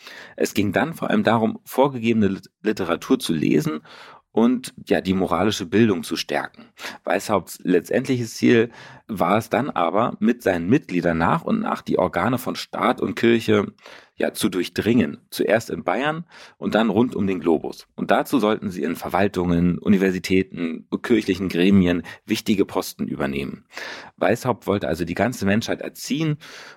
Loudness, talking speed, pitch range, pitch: -22 LUFS, 150 wpm, 90-115 Hz, 95 Hz